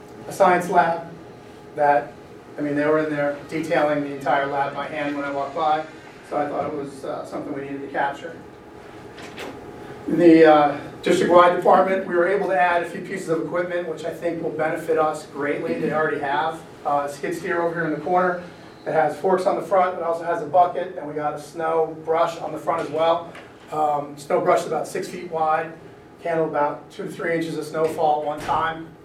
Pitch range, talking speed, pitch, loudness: 150-170 Hz, 220 wpm, 160 Hz, -22 LUFS